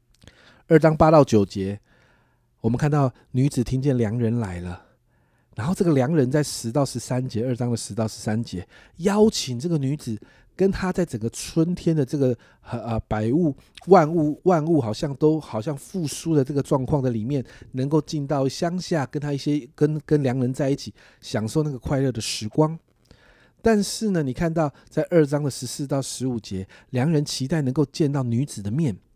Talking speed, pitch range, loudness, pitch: 270 characters per minute, 120-155 Hz, -23 LUFS, 140 Hz